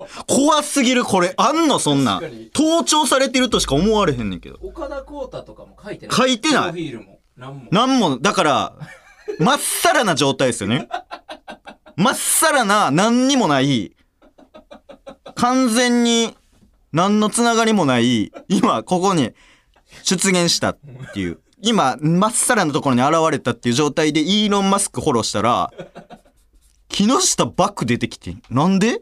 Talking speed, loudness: 270 characters per minute, -17 LUFS